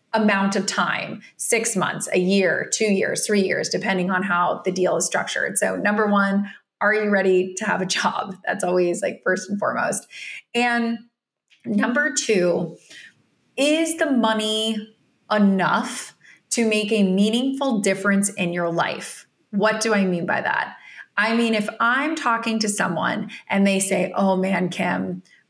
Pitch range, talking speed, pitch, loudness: 185-225 Hz, 160 wpm, 205 Hz, -21 LUFS